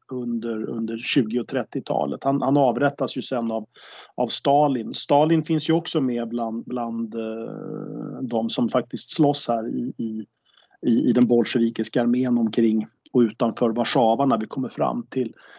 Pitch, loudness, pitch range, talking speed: 120 Hz, -23 LUFS, 115-130 Hz, 160 wpm